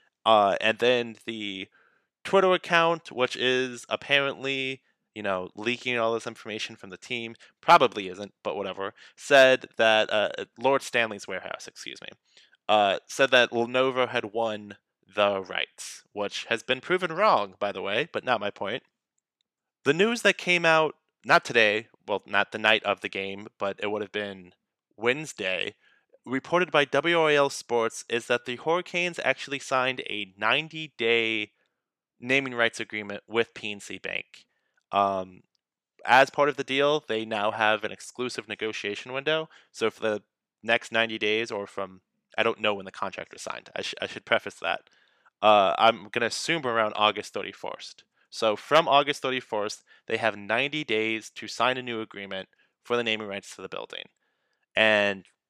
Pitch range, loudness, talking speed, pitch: 105-135 Hz, -26 LUFS, 165 wpm, 115 Hz